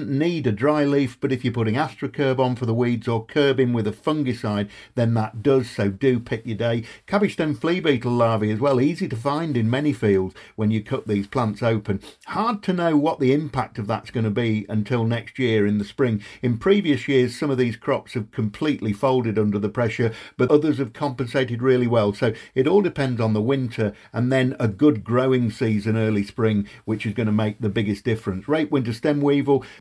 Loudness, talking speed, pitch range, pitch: -22 LUFS, 215 wpm, 110-140 Hz, 120 Hz